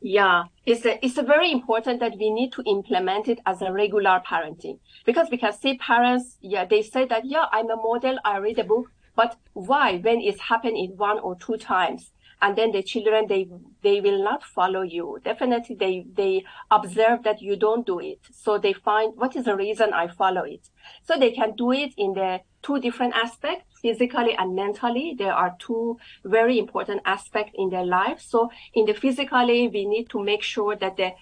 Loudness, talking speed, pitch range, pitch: -23 LUFS, 205 wpm, 200-245 Hz, 225 Hz